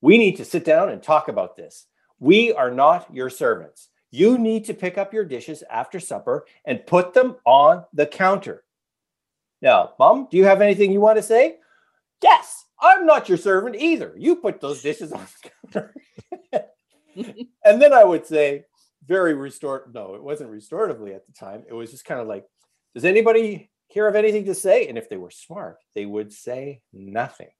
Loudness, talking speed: -18 LUFS, 190 wpm